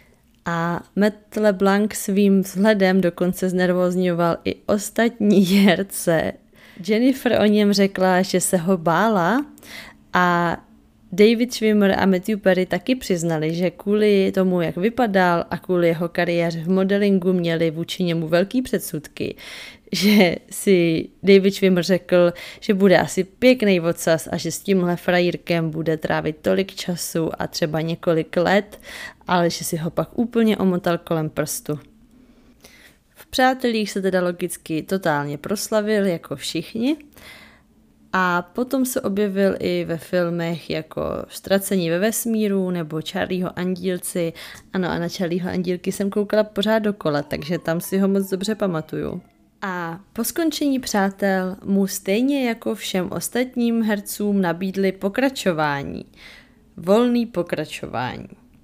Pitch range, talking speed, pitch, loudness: 170-210 Hz, 130 wpm, 190 Hz, -21 LUFS